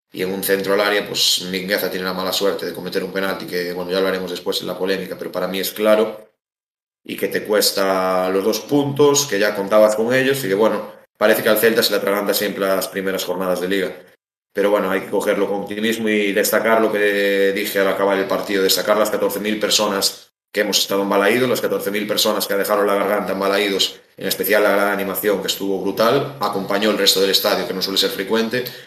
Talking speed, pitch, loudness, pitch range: 230 wpm, 100 Hz, -18 LUFS, 95-105 Hz